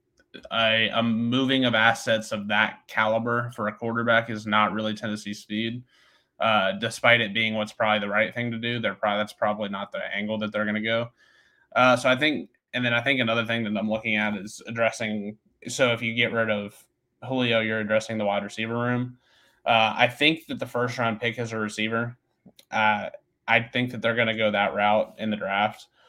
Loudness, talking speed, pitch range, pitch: -24 LUFS, 210 wpm, 105-120 Hz, 115 Hz